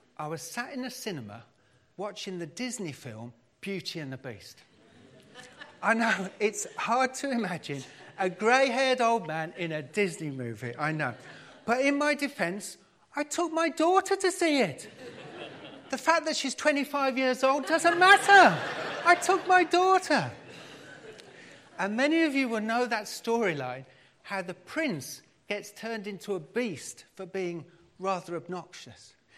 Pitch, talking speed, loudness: 210 Hz, 150 wpm, -27 LUFS